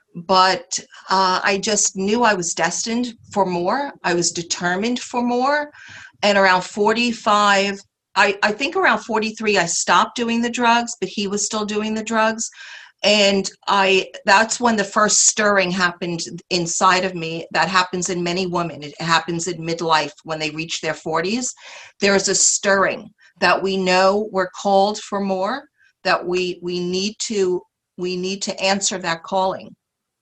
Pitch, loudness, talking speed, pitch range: 195 Hz, -19 LUFS, 165 wpm, 180-215 Hz